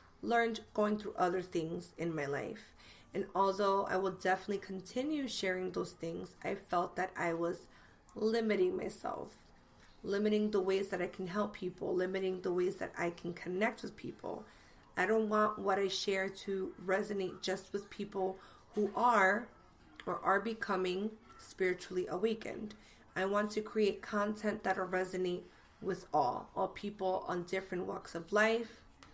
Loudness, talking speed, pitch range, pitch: -36 LUFS, 155 wpm, 180-210 Hz, 190 Hz